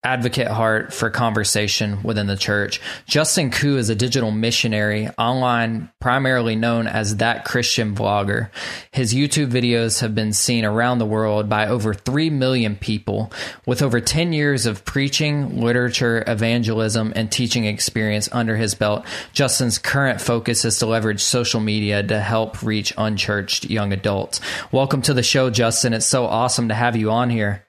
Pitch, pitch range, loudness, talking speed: 115 Hz, 110-125 Hz, -19 LUFS, 165 wpm